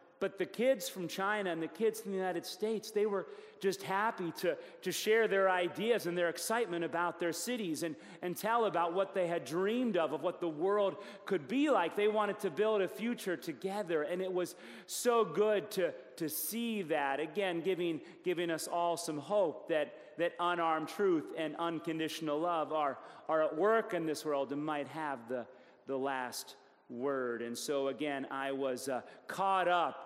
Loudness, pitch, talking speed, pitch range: -35 LUFS, 175 Hz, 190 wpm, 160-205 Hz